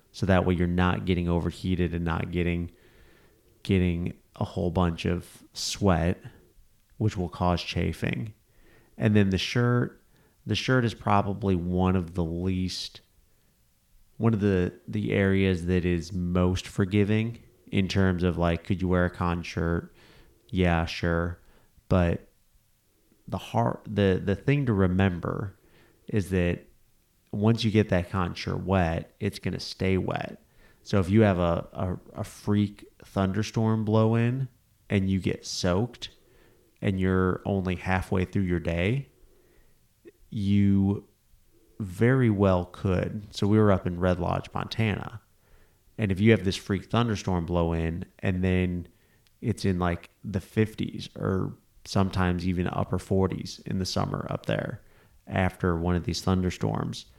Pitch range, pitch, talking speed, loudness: 90-105 Hz, 95 Hz, 145 wpm, -27 LUFS